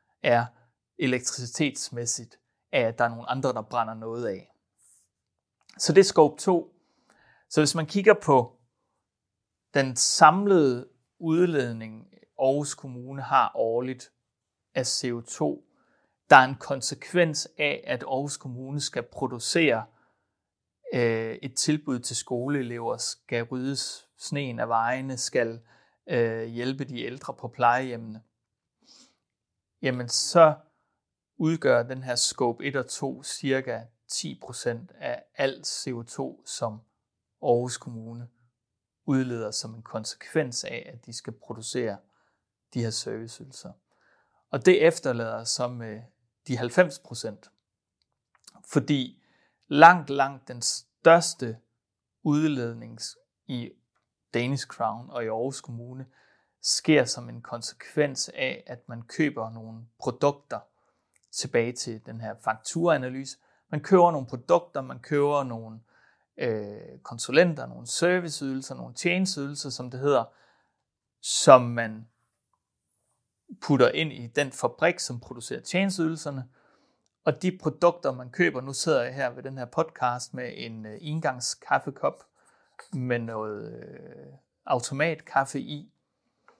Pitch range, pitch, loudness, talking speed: 115-145 Hz, 125 Hz, -26 LUFS, 115 wpm